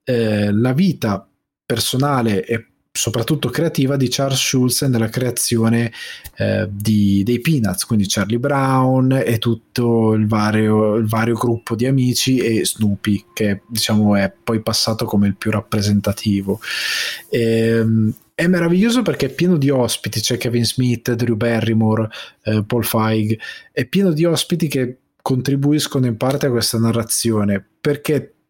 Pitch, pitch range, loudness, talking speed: 115 Hz, 110-130 Hz, -18 LUFS, 145 wpm